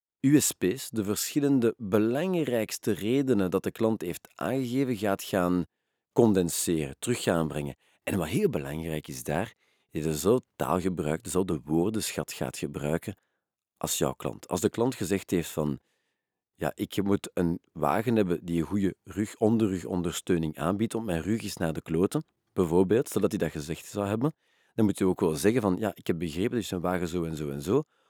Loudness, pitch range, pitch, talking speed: -29 LUFS, 85-110 Hz, 95 Hz, 185 wpm